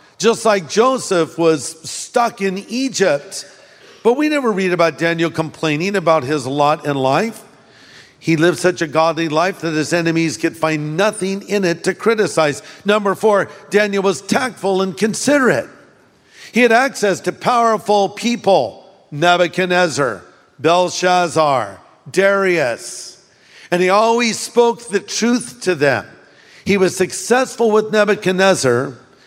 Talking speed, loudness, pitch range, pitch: 130 wpm, -16 LUFS, 165-215 Hz, 190 Hz